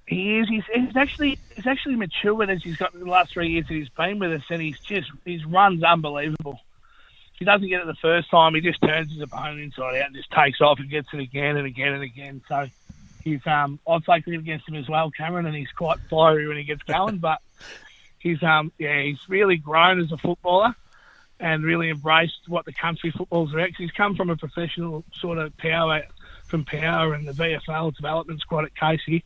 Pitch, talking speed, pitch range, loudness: 160 Hz, 220 wpm, 150-175 Hz, -23 LUFS